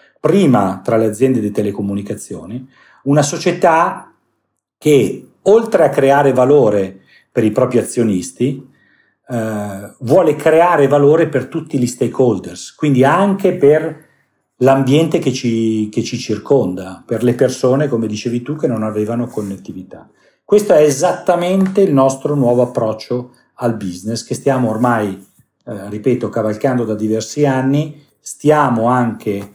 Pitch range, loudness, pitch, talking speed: 110-145 Hz, -15 LUFS, 125 Hz, 130 wpm